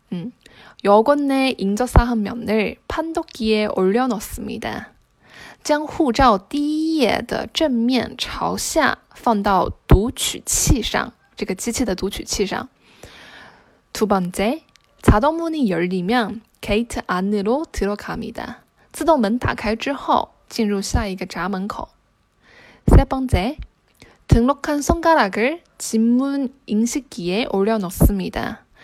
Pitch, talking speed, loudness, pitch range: 235 Hz, 215 characters per minute, -20 LUFS, 205-280 Hz